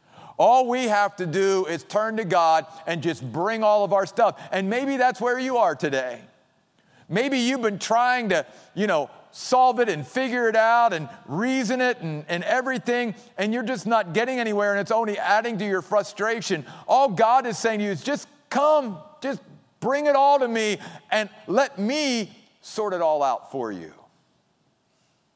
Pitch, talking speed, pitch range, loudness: 225 Hz, 185 wpm, 195-250 Hz, -23 LUFS